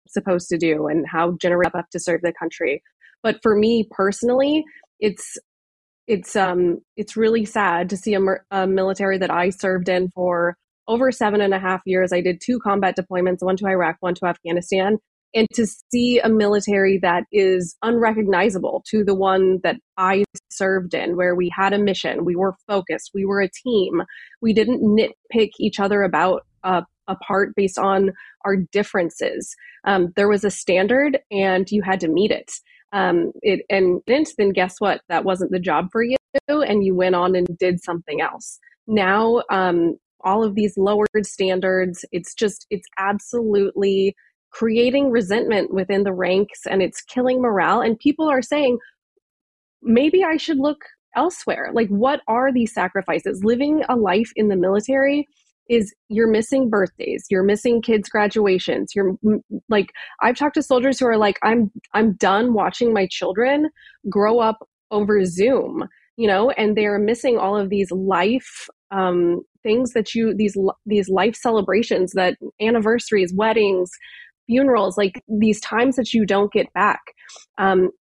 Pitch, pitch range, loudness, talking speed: 205 Hz, 185-230 Hz, -20 LUFS, 165 wpm